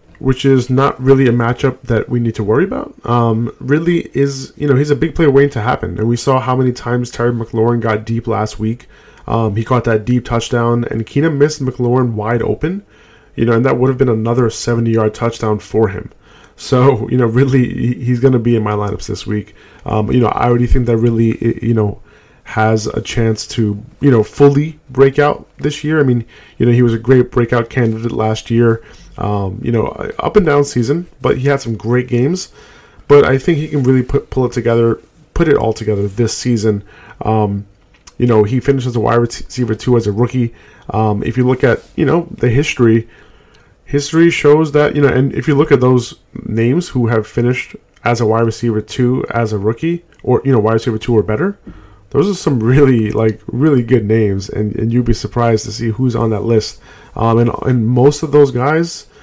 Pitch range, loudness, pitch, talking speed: 110-135 Hz, -14 LUFS, 120 Hz, 220 wpm